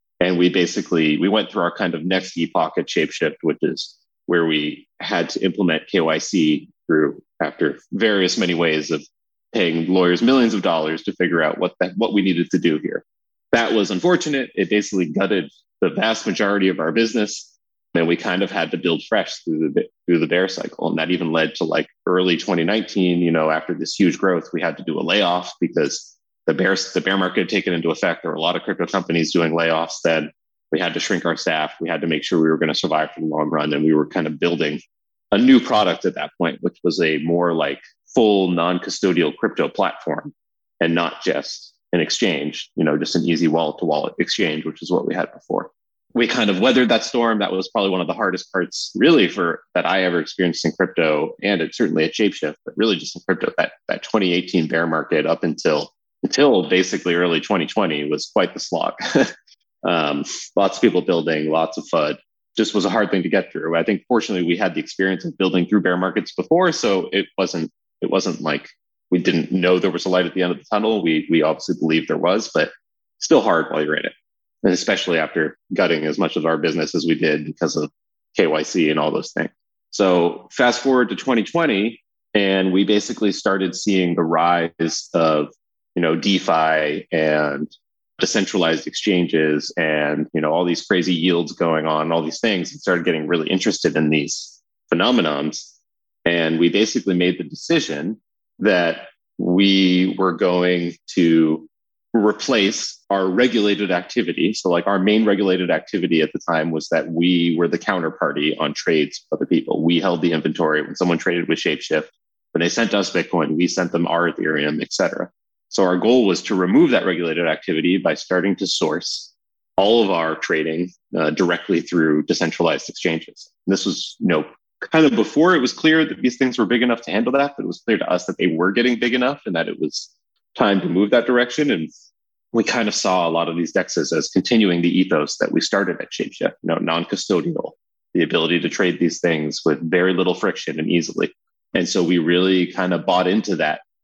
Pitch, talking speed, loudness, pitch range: 90 Hz, 210 wpm, -19 LUFS, 80-95 Hz